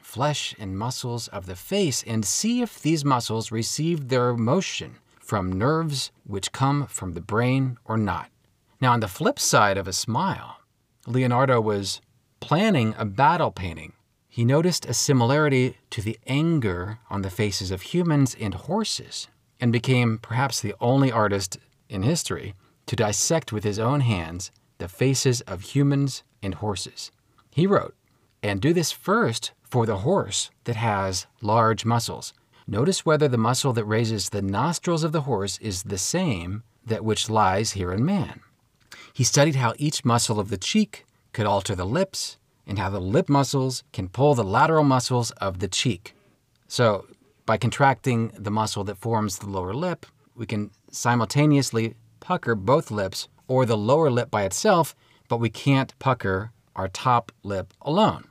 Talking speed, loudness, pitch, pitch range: 165 wpm, -24 LUFS, 115 Hz, 105-135 Hz